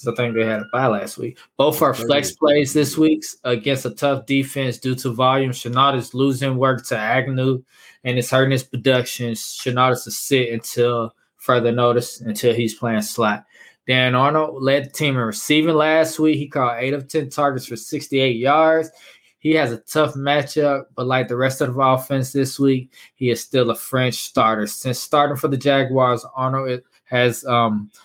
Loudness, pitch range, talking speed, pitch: -19 LUFS, 120-140 Hz, 190 wpm, 130 Hz